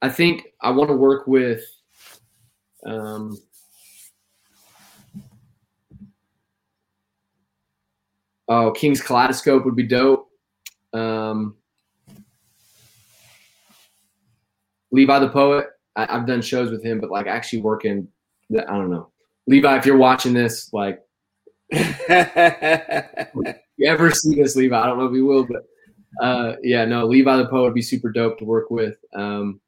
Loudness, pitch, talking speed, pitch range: -19 LUFS, 120 Hz, 125 wpm, 110-135 Hz